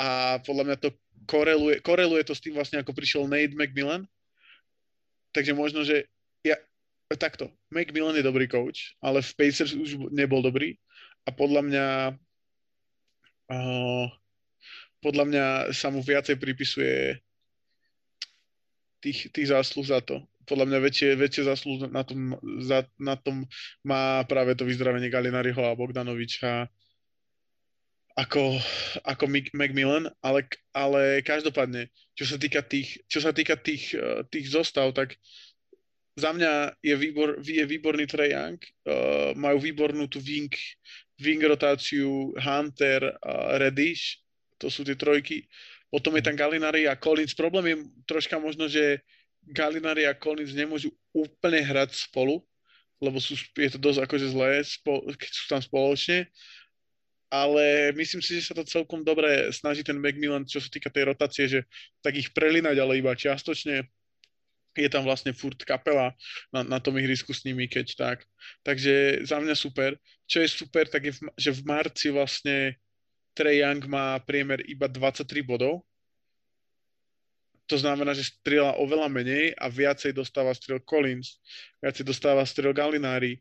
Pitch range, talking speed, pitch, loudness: 135-150 Hz, 140 wpm, 140 Hz, -26 LUFS